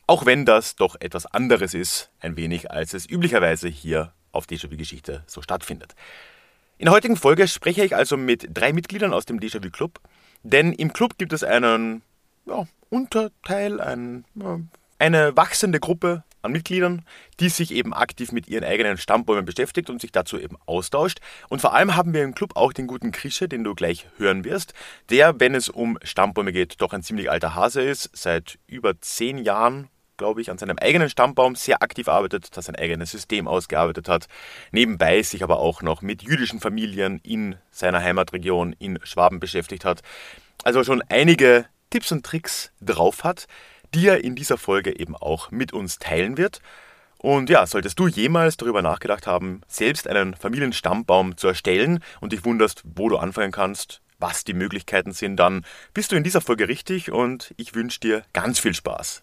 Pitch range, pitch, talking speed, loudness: 105-175 Hz, 125 Hz, 180 wpm, -21 LUFS